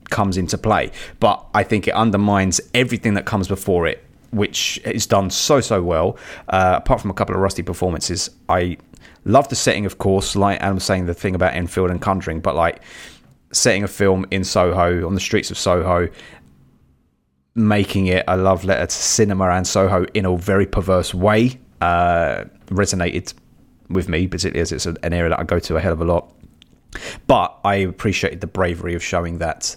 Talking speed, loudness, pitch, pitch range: 190 wpm, -19 LUFS, 95 Hz, 85-100 Hz